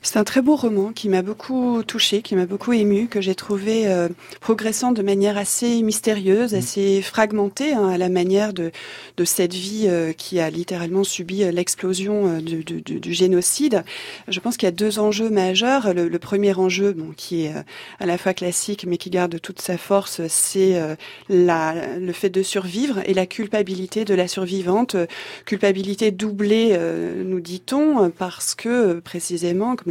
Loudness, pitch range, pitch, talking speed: -20 LUFS, 180-215 Hz, 195 Hz, 185 wpm